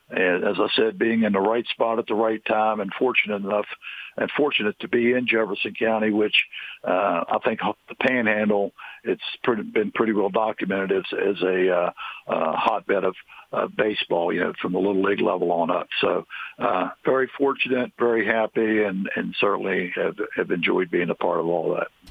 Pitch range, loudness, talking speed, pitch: 100-115 Hz, -23 LUFS, 195 wpm, 110 Hz